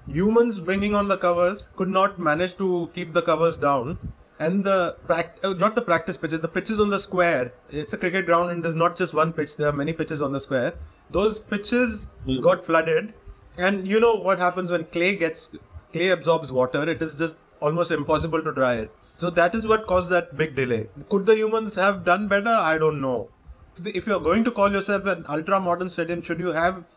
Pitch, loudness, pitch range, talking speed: 175 Hz, -23 LUFS, 155-195 Hz, 210 wpm